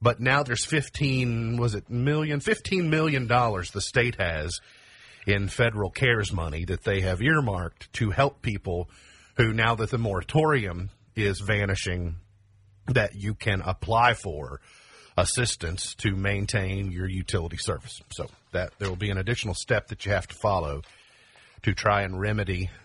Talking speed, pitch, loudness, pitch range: 155 wpm, 105 Hz, -26 LUFS, 95-120 Hz